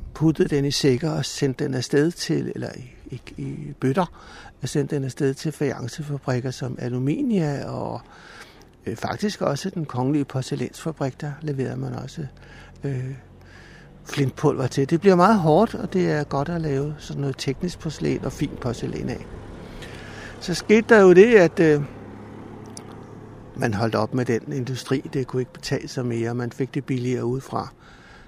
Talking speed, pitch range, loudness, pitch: 160 wpm, 125-155 Hz, -23 LUFS, 140 Hz